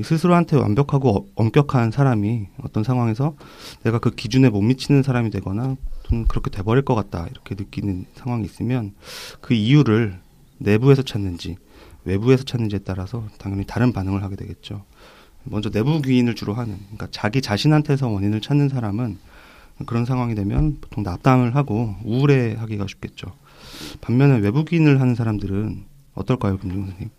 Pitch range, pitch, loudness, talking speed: 100-130 Hz, 115 Hz, -20 LUFS, 375 characters per minute